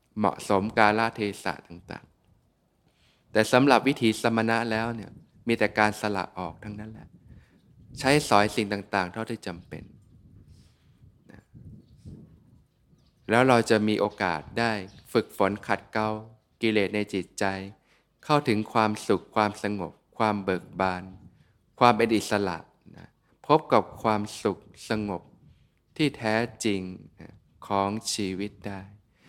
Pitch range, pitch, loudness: 95-110 Hz, 105 Hz, -26 LUFS